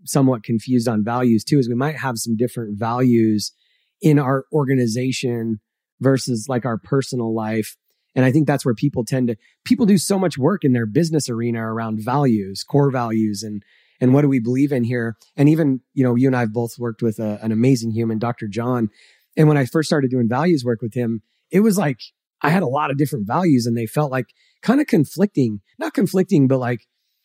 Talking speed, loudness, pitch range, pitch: 210 wpm, -19 LUFS, 115-140 Hz, 125 Hz